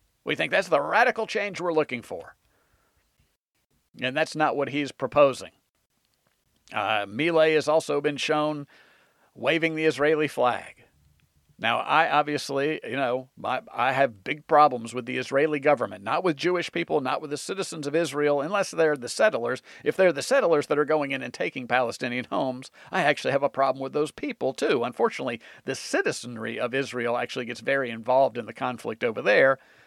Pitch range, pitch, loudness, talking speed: 130-155 Hz, 145 Hz, -25 LUFS, 175 wpm